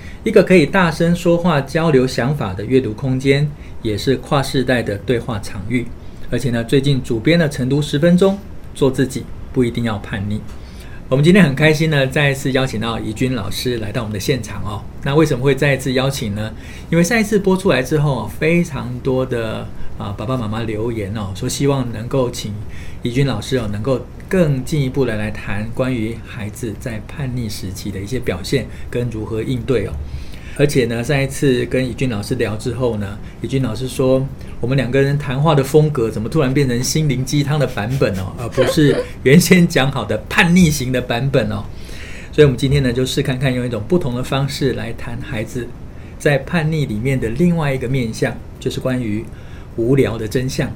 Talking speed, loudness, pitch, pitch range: 300 characters per minute, -17 LUFS, 130 Hz, 110-140 Hz